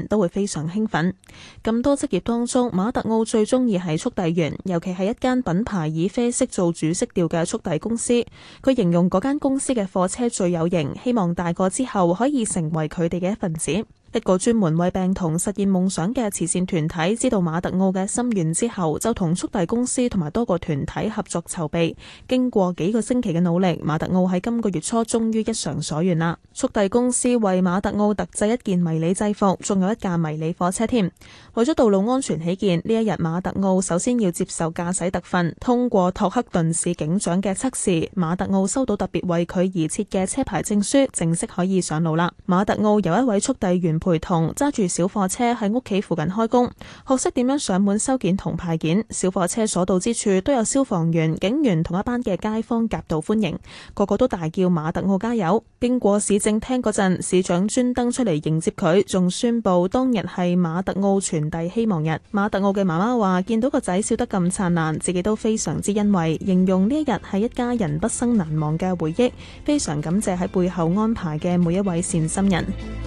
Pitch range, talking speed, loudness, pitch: 175-225 Hz, 305 characters per minute, -21 LUFS, 195 Hz